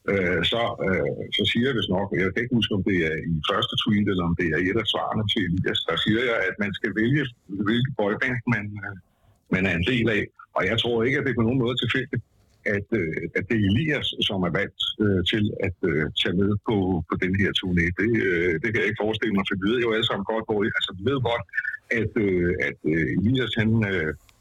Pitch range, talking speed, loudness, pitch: 95-120 Hz, 240 wpm, -24 LUFS, 105 Hz